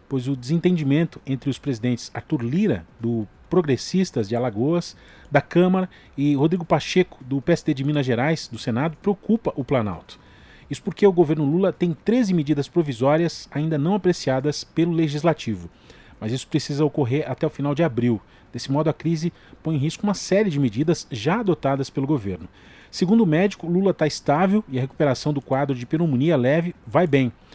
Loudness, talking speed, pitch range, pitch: -22 LUFS, 175 wpm, 130-170 Hz, 150 Hz